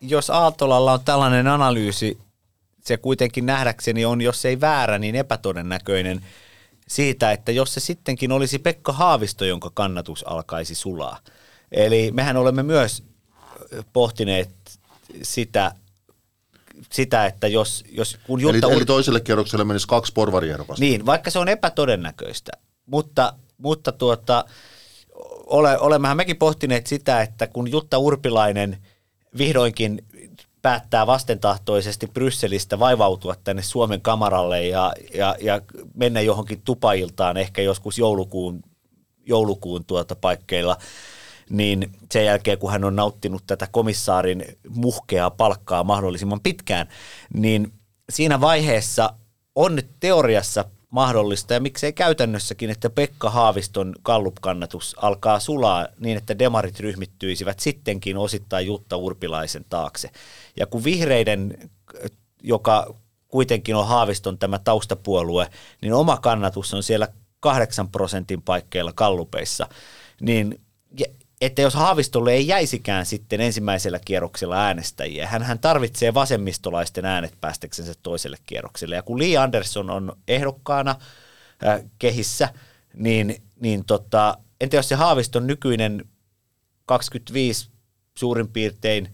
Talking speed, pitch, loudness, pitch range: 115 wpm, 110 Hz, -21 LUFS, 100-130 Hz